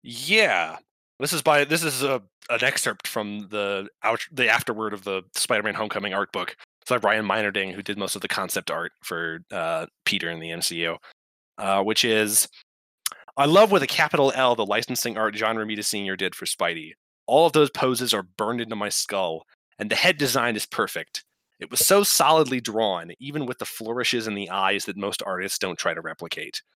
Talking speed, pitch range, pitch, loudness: 200 wpm, 100-135 Hz, 110 Hz, -23 LUFS